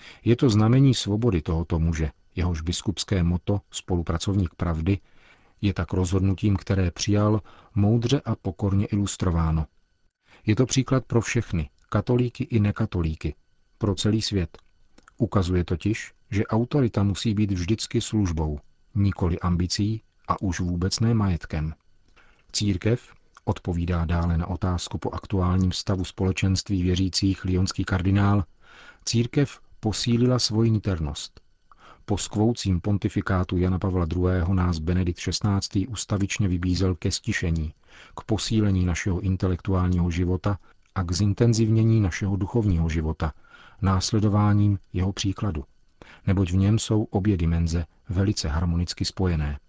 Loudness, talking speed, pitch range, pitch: -25 LUFS, 120 wpm, 90-105 Hz, 95 Hz